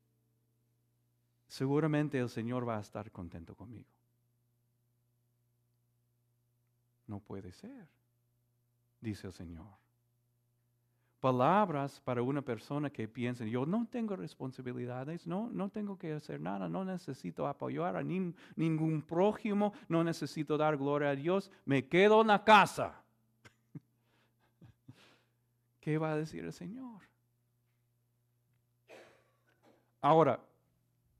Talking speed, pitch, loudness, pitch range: 105 wpm, 120 Hz, -33 LUFS, 120-155 Hz